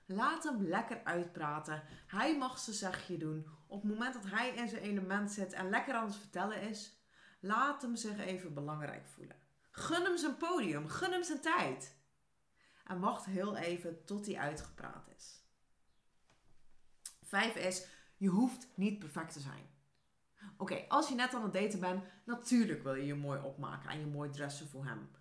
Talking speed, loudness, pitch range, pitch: 180 wpm, -39 LUFS, 165-235 Hz, 195 Hz